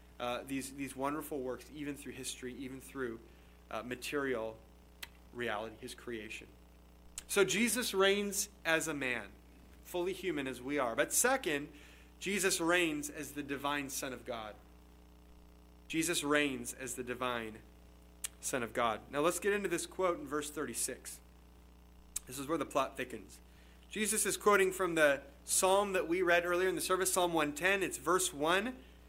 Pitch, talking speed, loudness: 135 Hz, 165 wpm, -35 LUFS